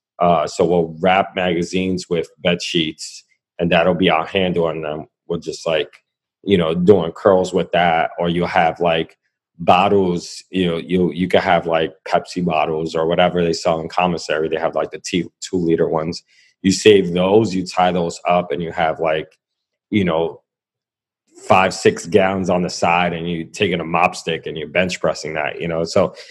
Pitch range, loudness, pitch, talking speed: 80-90 Hz, -18 LUFS, 90 Hz, 195 wpm